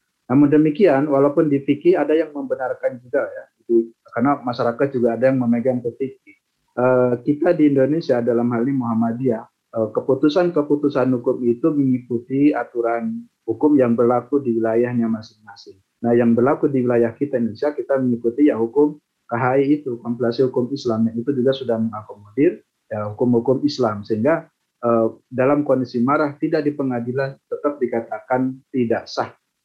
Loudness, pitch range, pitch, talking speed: -19 LUFS, 120-145 Hz, 130 Hz, 150 wpm